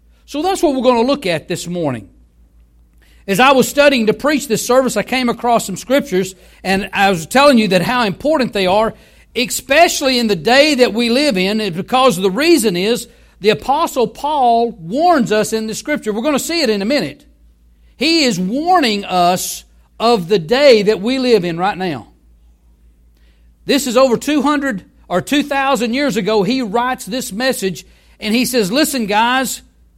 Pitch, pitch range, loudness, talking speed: 230 Hz, 185-265 Hz, -14 LUFS, 180 wpm